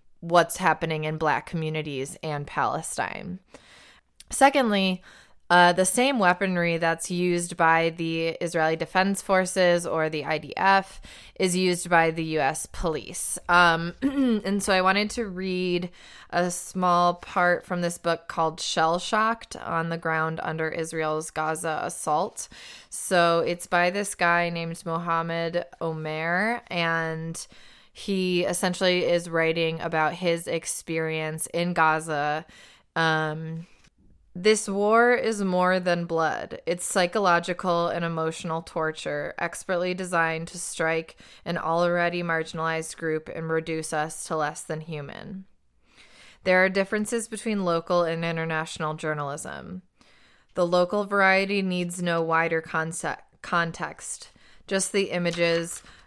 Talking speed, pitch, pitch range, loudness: 125 wpm, 170 Hz, 160-185 Hz, -25 LUFS